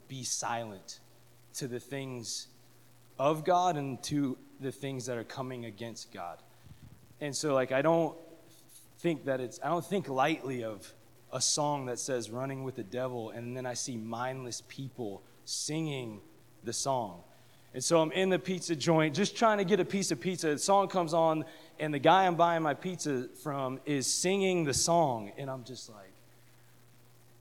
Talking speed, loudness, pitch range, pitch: 175 wpm, -32 LUFS, 120-160 Hz, 130 Hz